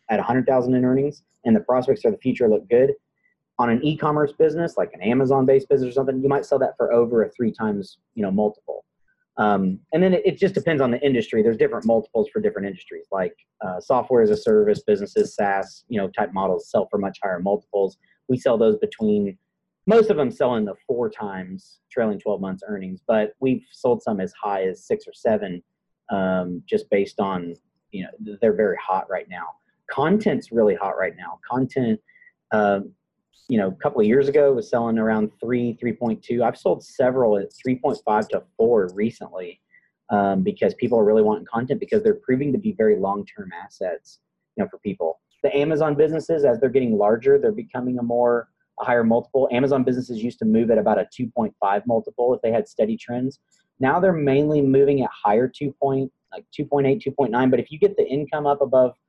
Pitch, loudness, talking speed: 135 Hz, -21 LUFS, 210 wpm